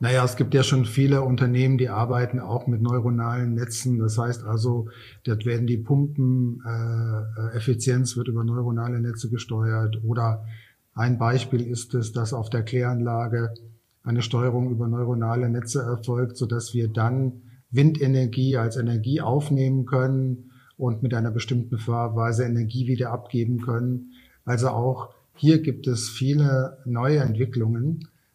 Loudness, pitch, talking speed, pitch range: -24 LUFS, 120 Hz, 140 wpm, 115-130 Hz